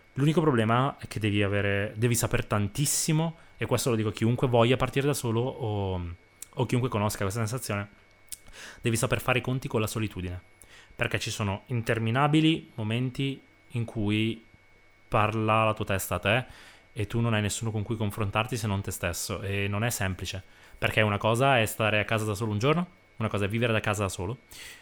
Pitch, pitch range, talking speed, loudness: 110 Hz, 100-120 Hz, 195 wpm, -28 LUFS